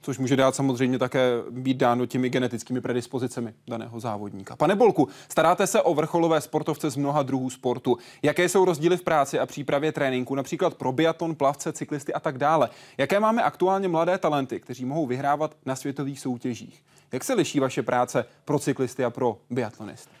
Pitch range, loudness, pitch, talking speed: 125-155 Hz, -25 LUFS, 135 Hz, 180 wpm